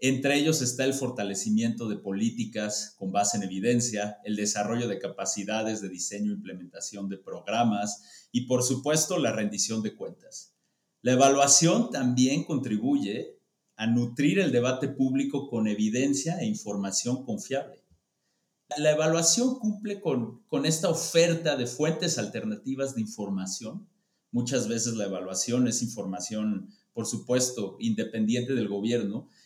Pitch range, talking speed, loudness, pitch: 105-150 Hz, 130 wpm, -27 LUFS, 120 Hz